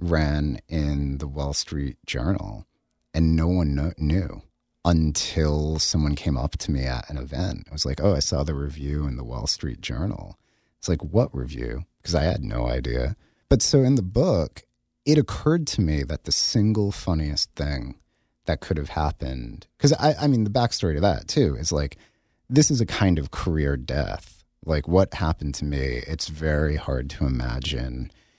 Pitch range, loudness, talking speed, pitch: 70-90 Hz, -24 LUFS, 185 wpm, 75 Hz